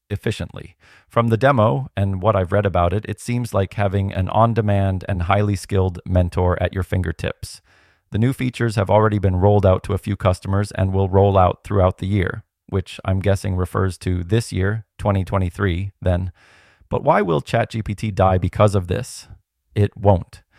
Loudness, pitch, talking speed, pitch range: -20 LUFS, 100 Hz, 180 wpm, 95-105 Hz